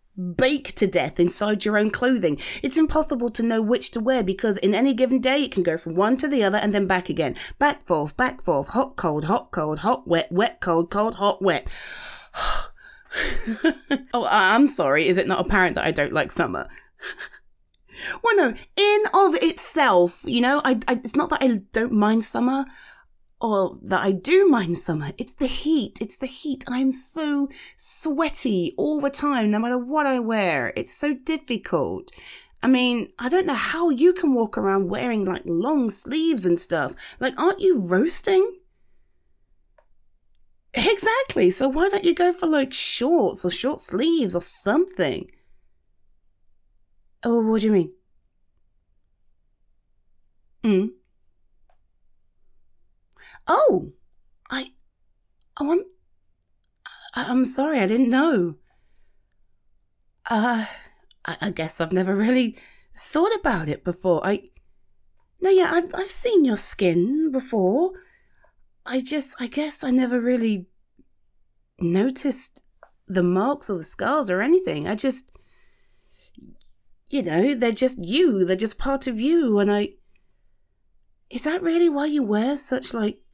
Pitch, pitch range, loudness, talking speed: 240 Hz, 180-290 Hz, -21 LUFS, 150 wpm